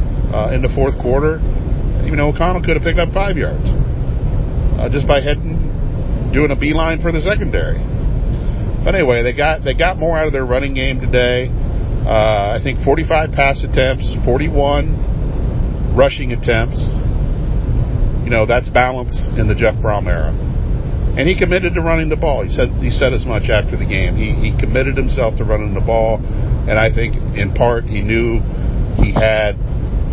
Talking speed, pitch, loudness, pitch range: 175 wpm, 125 Hz, -16 LUFS, 110-140 Hz